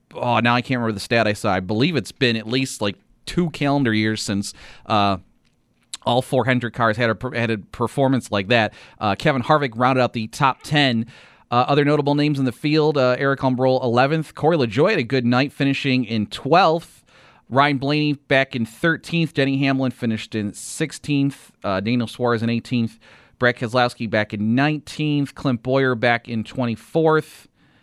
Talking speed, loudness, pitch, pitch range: 180 wpm, -20 LUFS, 125 Hz, 115-140 Hz